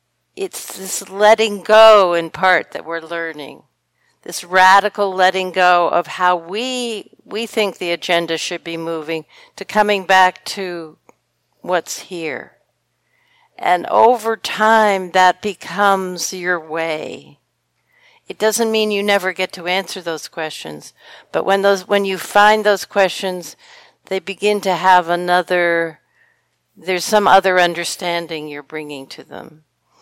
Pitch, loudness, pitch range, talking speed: 185 Hz, -16 LUFS, 170-205 Hz, 135 wpm